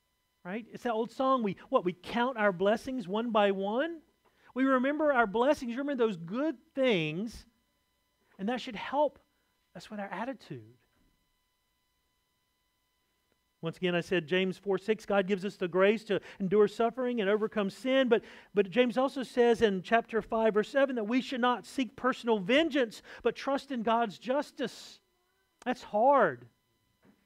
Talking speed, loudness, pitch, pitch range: 160 wpm, -30 LUFS, 225 Hz, 195-255 Hz